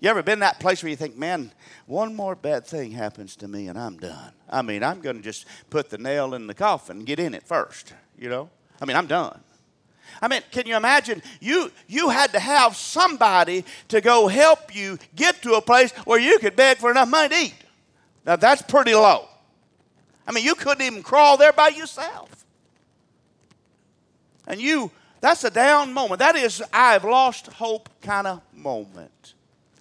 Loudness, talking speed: -19 LUFS, 195 wpm